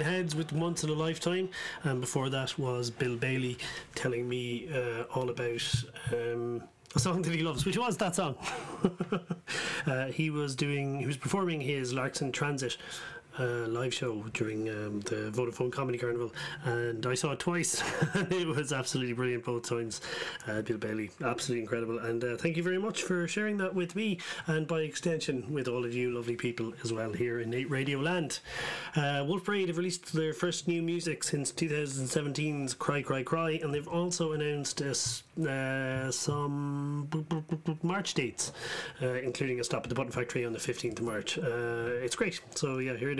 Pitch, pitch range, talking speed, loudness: 140 Hz, 120-160 Hz, 190 wpm, -33 LUFS